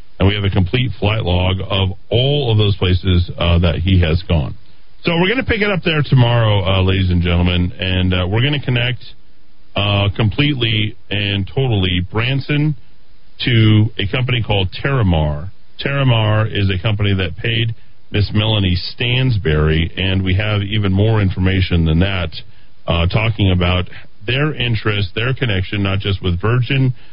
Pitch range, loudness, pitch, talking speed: 95-115 Hz, -16 LUFS, 100 Hz, 165 wpm